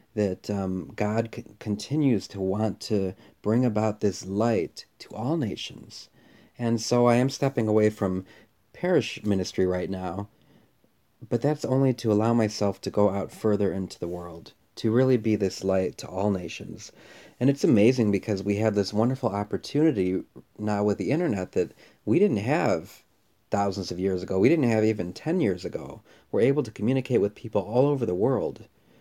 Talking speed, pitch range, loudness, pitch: 175 wpm, 95-115 Hz, -26 LUFS, 105 Hz